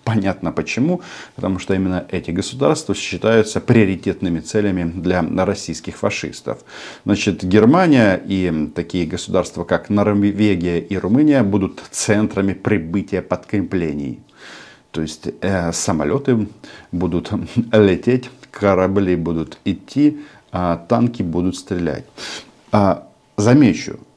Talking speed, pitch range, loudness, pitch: 100 wpm, 85-105 Hz, -18 LUFS, 95 Hz